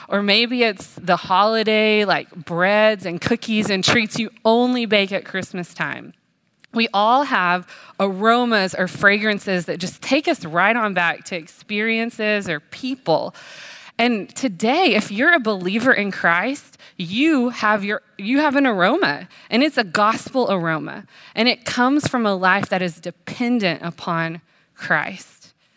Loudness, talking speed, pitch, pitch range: -19 LUFS, 150 wpm, 210 Hz, 185-235 Hz